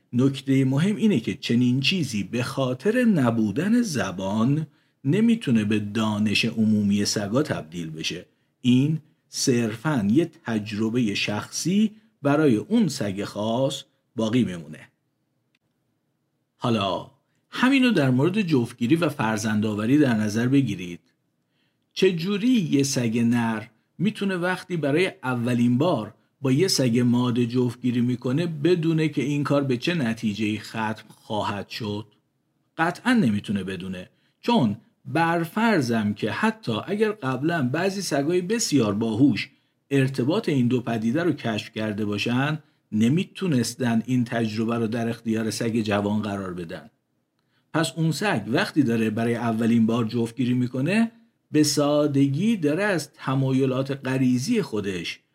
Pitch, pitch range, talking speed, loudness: 130 Hz, 115-155 Hz, 120 wpm, -24 LUFS